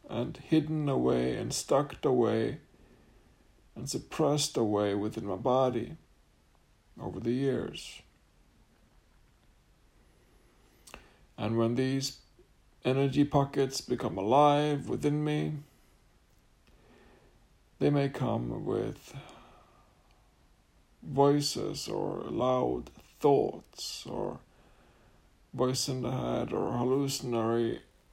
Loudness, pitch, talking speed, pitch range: -30 LUFS, 130 Hz, 85 wpm, 115-140 Hz